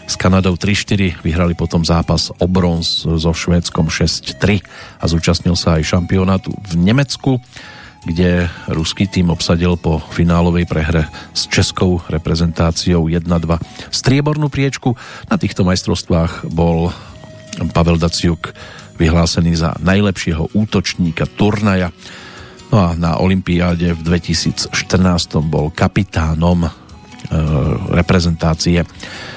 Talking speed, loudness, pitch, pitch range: 105 wpm, -15 LUFS, 85 Hz, 85-95 Hz